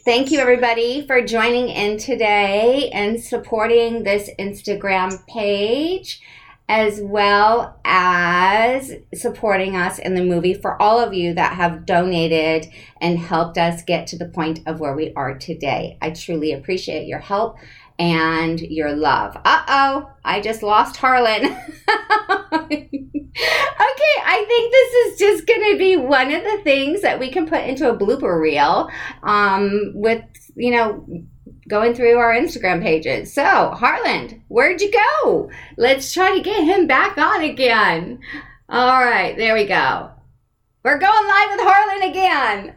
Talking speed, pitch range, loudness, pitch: 150 wpm, 185-290 Hz, -17 LUFS, 225 Hz